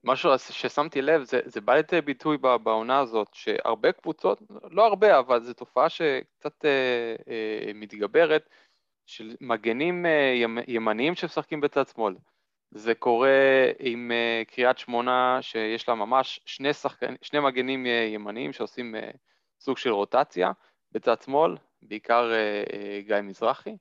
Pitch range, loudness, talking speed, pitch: 115-140 Hz, -25 LUFS, 135 wpm, 125 Hz